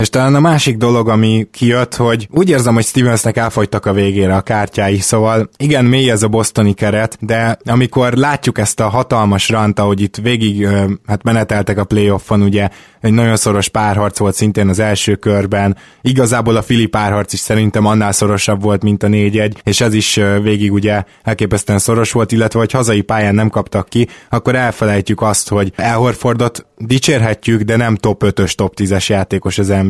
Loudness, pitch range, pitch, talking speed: -13 LUFS, 100-115 Hz, 110 Hz, 180 wpm